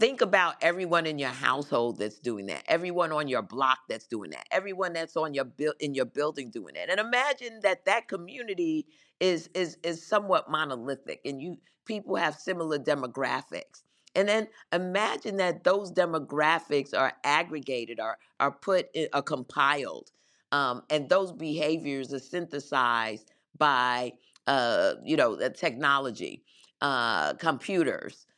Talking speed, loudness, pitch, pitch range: 150 wpm, -29 LUFS, 155 Hz, 140-185 Hz